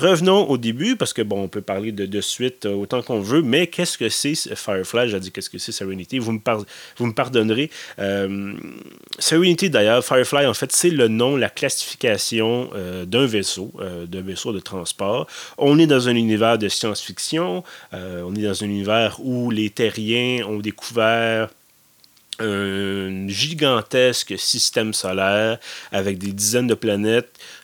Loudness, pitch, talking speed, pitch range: -20 LUFS, 110 Hz, 170 wpm, 100-125 Hz